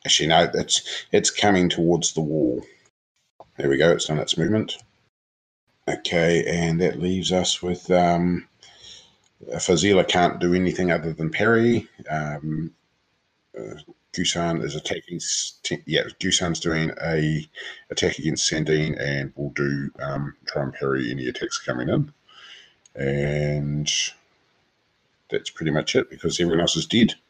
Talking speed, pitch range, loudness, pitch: 135 wpm, 75-90 Hz, -23 LUFS, 80 Hz